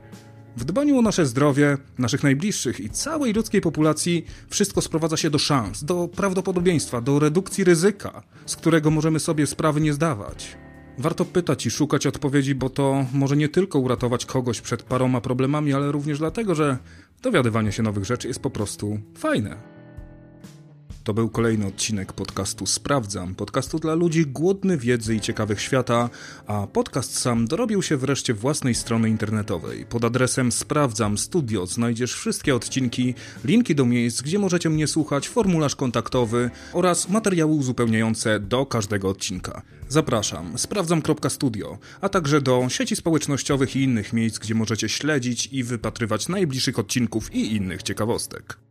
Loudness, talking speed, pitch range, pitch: -23 LUFS, 150 wpm, 115-155 Hz, 135 Hz